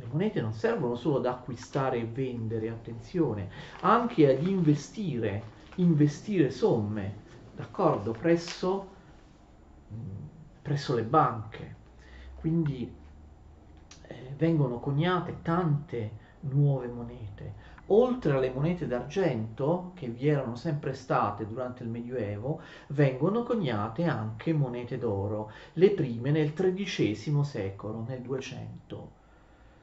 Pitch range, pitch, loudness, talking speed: 110-160 Hz, 130 Hz, -29 LUFS, 105 wpm